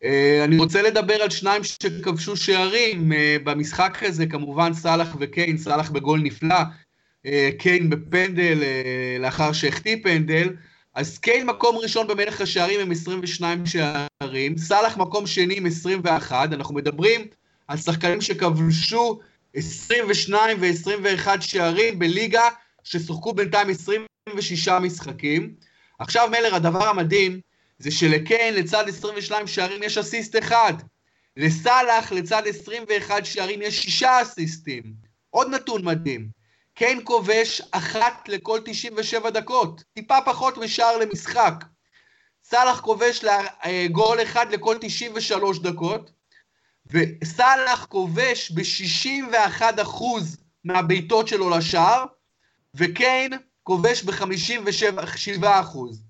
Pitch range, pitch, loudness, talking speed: 165-220 Hz, 190 Hz, -21 LUFS, 105 wpm